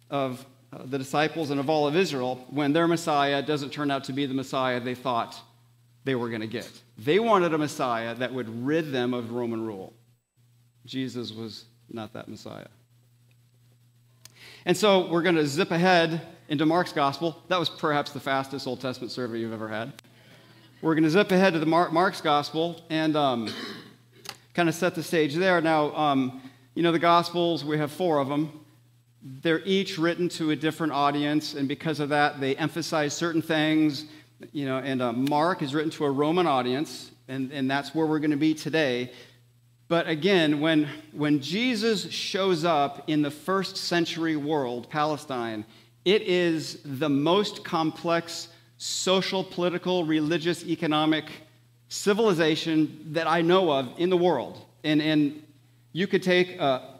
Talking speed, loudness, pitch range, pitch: 170 wpm, -26 LUFS, 125-165 Hz, 150 Hz